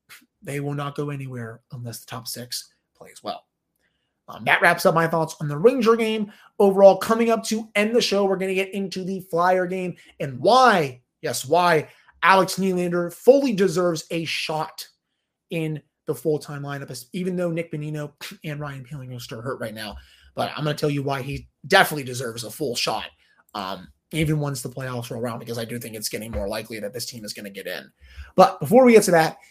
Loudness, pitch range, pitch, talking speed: -22 LUFS, 130-185 Hz, 155 Hz, 215 wpm